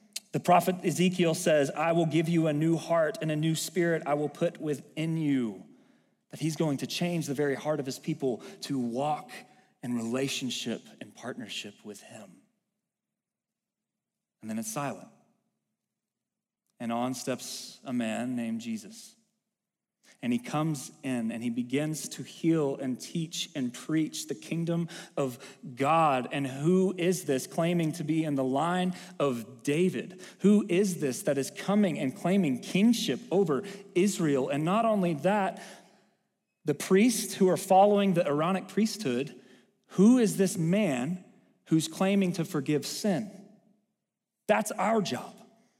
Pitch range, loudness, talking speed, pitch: 145-205 Hz, -29 LUFS, 150 wpm, 175 Hz